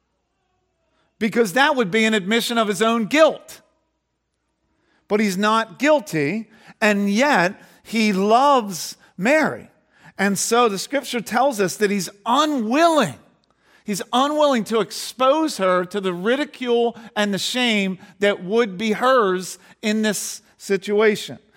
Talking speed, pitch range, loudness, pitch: 130 wpm, 200-245 Hz, -20 LUFS, 220 Hz